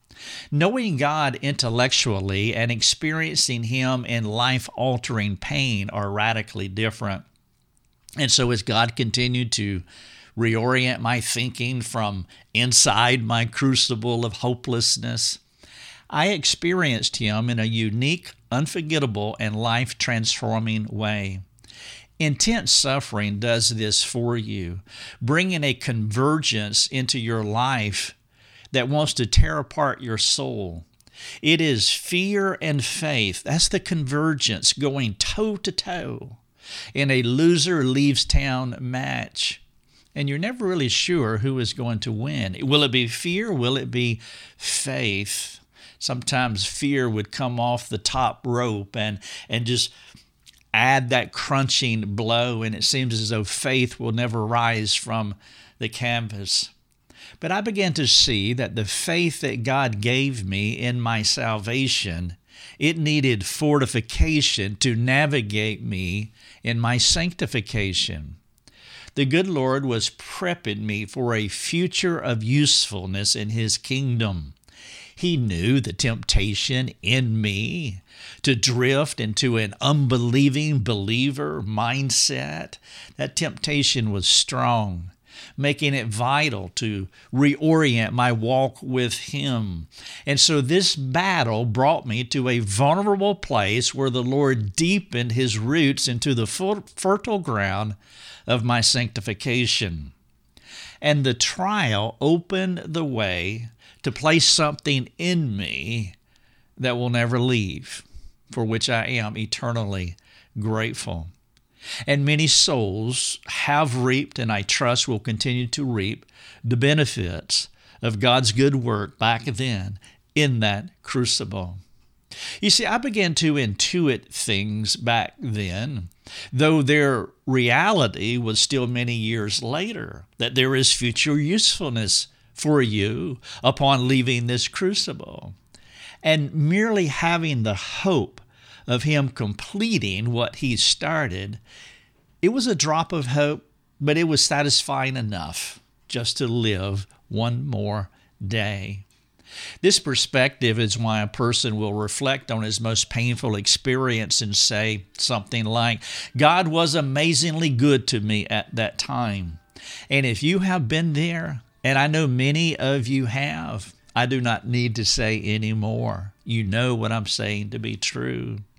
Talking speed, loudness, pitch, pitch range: 130 wpm, -22 LUFS, 120 Hz, 110-140 Hz